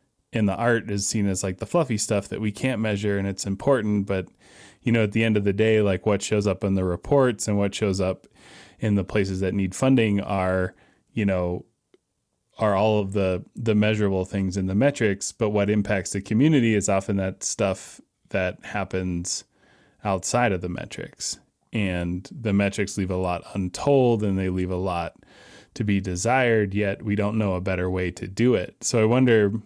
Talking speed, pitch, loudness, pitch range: 200 wpm, 100 Hz, -24 LUFS, 95-110 Hz